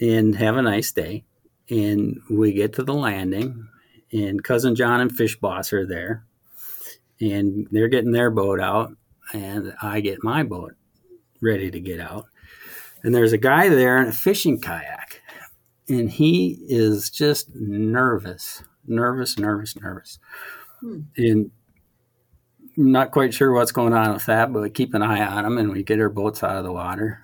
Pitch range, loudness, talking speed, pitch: 105-125 Hz, -21 LUFS, 170 wpm, 110 Hz